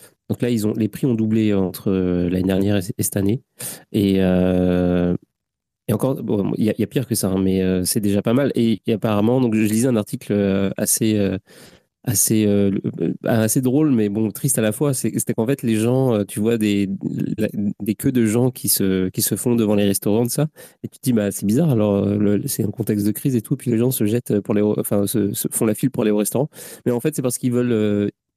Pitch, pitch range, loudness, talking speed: 110 Hz, 100-120 Hz, -20 LUFS, 240 wpm